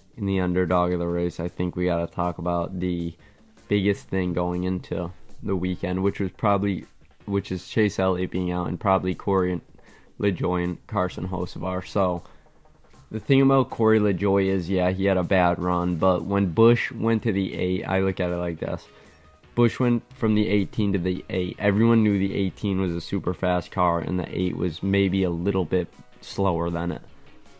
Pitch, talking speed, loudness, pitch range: 90 Hz, 195 wpm, -24 LUFS, 90-100 Hz